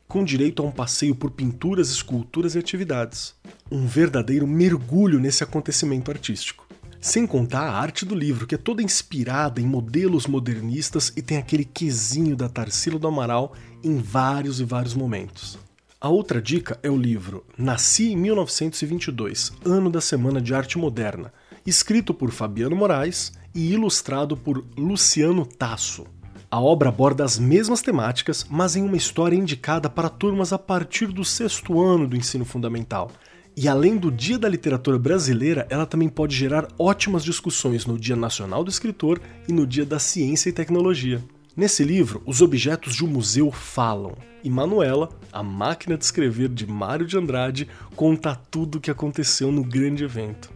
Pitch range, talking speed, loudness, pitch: 125-170 Hz, 165 wpm, -22 LUFS, 145 Hz